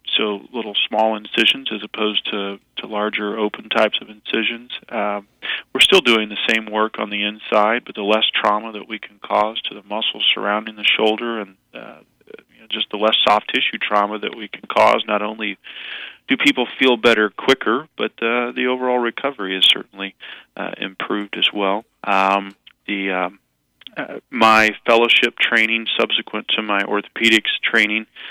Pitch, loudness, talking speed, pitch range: 105 Hz, -18 LUFS, 170 wpm, 105-115 Hz